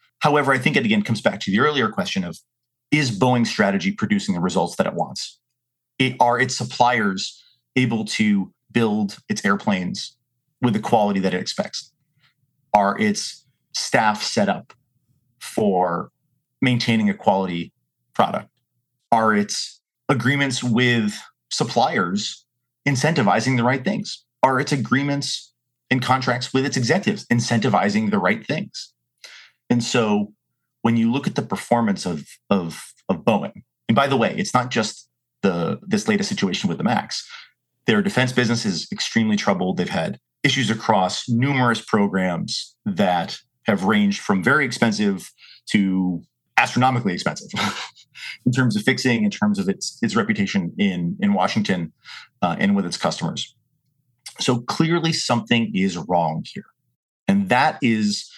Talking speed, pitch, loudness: 145 wpm, 125 Hz, -21 LUFS